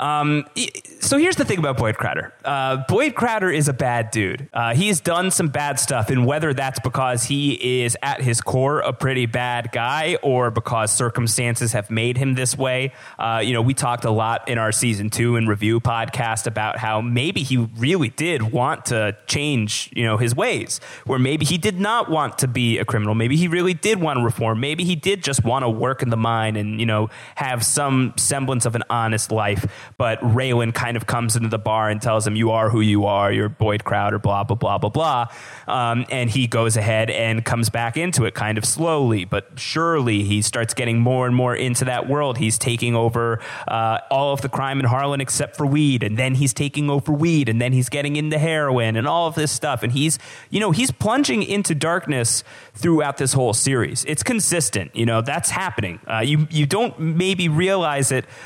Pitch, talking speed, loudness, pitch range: 125 Hz, 215 wpm, -20 LUFS, 115-145 Hz